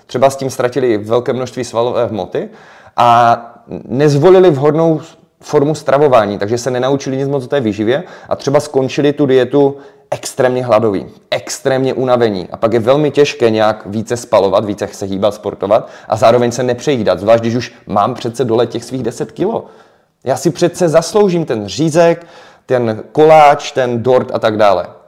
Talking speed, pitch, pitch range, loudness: 165 wpm, 130 Hz, 115-150 Hz, -13 LUFS